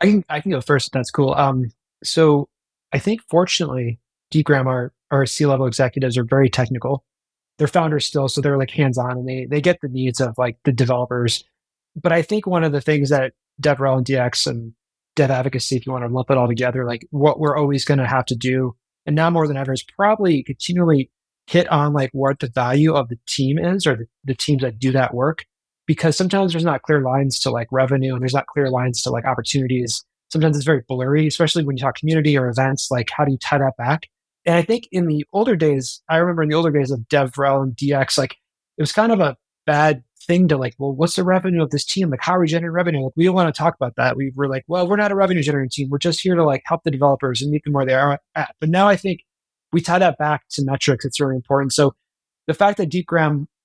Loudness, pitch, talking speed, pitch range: -19 LUFS, 140 Hz, 250 wpm, 130-160 Hz